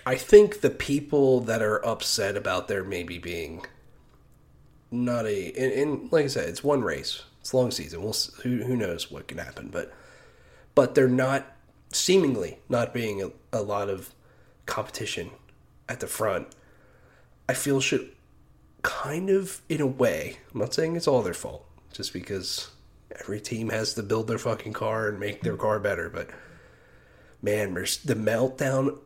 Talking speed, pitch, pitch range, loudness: 165 wpm, 125 Hz, 110-140 Hz, -27 LUFS